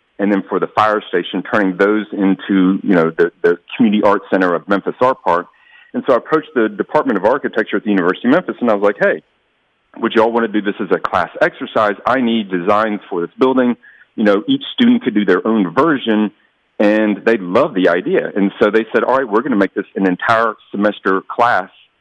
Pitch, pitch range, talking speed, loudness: 110 Hz, 100-130 Hz, 230 wpm, -15 LUFS